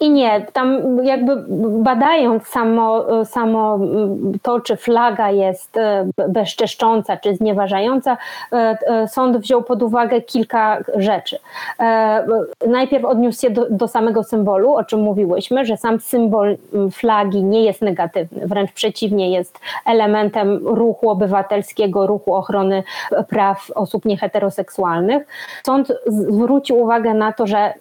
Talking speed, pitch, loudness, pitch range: 115 wpm, 220 Hz, -17 LUFS, 205-240 Hz